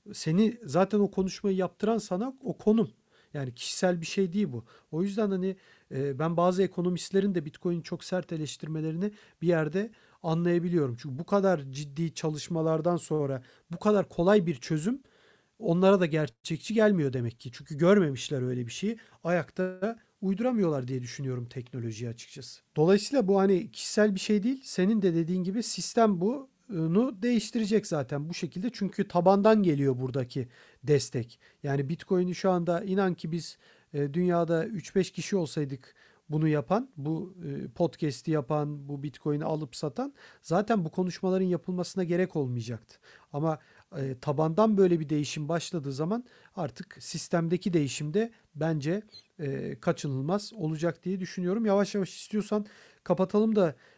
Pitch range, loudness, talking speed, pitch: 150-195 Hz, -29 LUFS, 140 wpm, 175 Hz